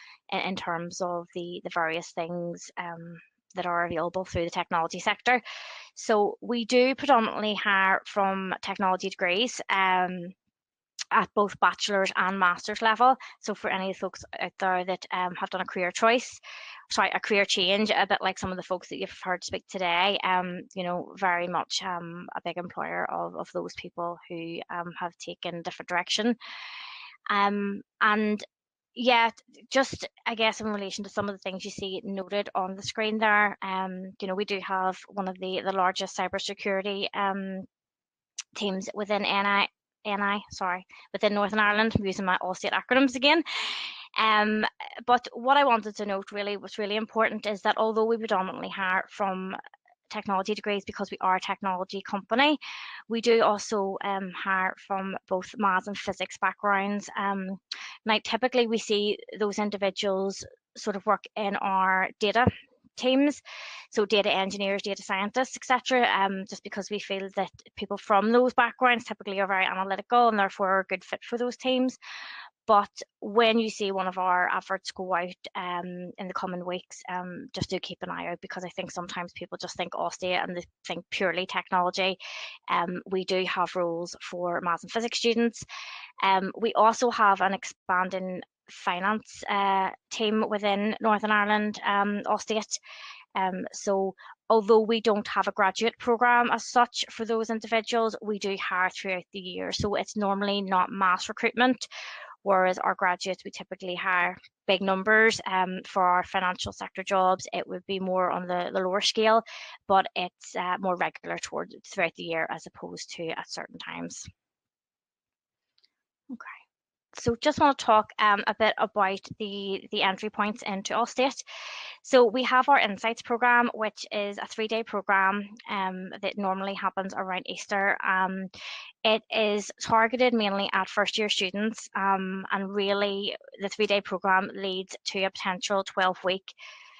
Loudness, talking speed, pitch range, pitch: -27 LUFS, 170 wpm, 185-220 Hz, 200 Hz